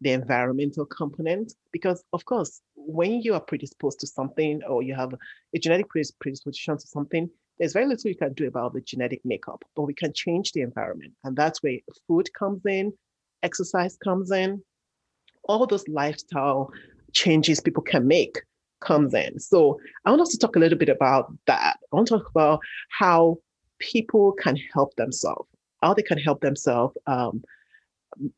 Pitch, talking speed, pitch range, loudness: 165 Hz, 175 wpm, 145-200 Hz, -24 LUFS